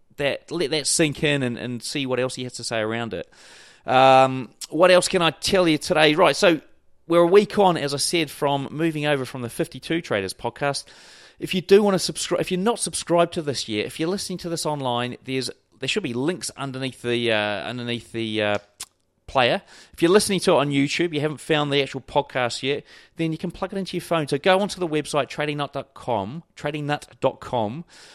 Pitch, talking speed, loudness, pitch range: 145 Hz, 215 wpm, -22 LUFS, 130-170 Hz